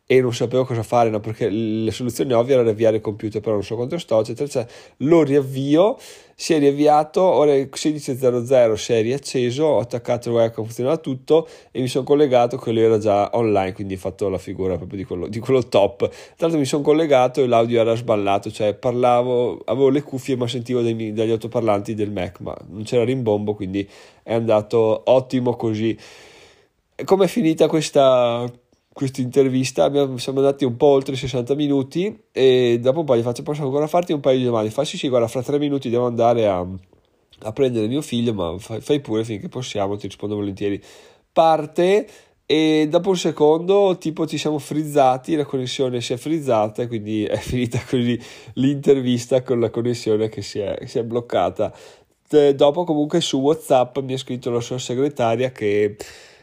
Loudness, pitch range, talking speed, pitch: -20 LUFS, 110-145 Hz, 190 wpm, 125 Hz